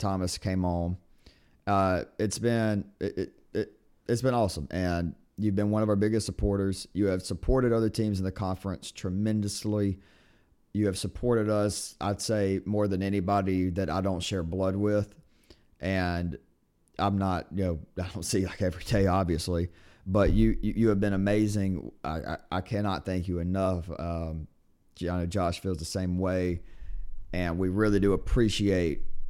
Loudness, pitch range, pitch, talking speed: -29 LUFS, 90-105 Hz, 95 Hz, 170 wpm